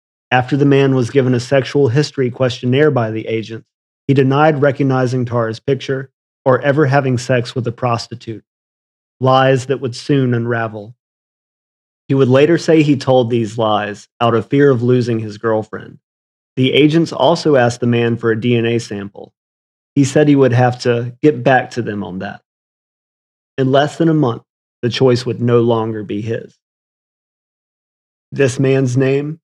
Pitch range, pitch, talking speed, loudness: 115-140 Hz, 125 Hz, 165 wpm, -15 LUFS